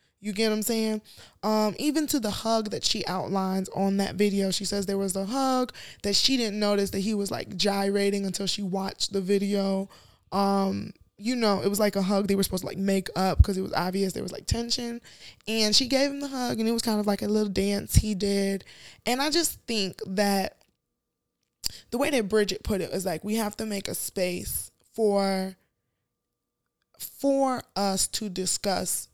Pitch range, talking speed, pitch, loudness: 195-225 Hz, 205 wpm, 205 Hz, -27 LUFS